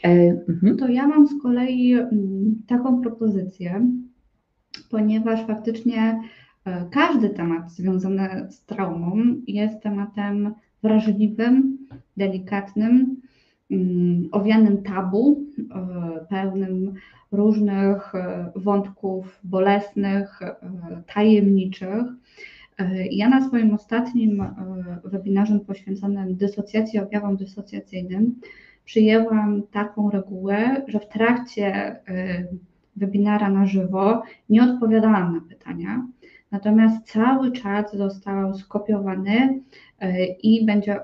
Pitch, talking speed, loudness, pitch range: 205 Hz, 80 wpm, -21 LUFS, 195-225 Hz